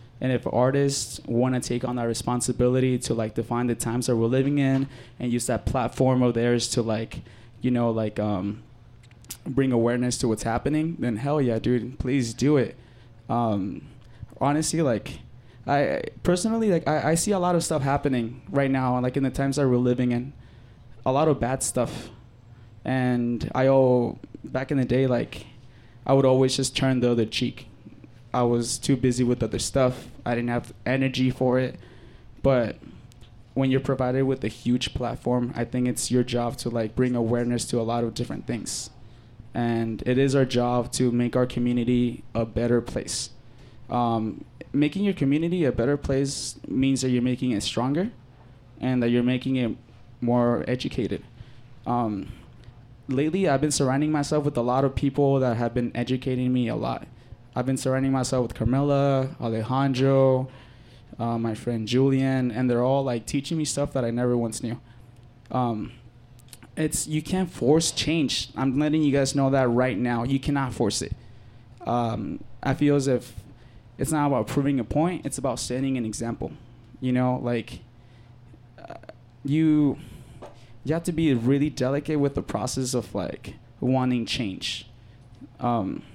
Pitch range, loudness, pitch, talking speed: 120-135 Hz, -25 LUFS, 125 Hz, 175 wpm